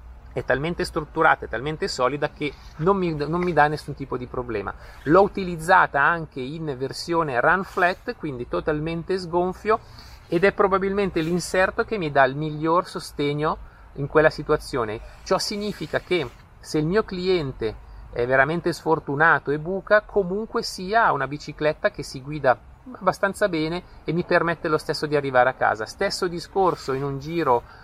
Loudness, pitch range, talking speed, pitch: -23 LUFS, 145-185 Hz, 160 wpm, 160 Hz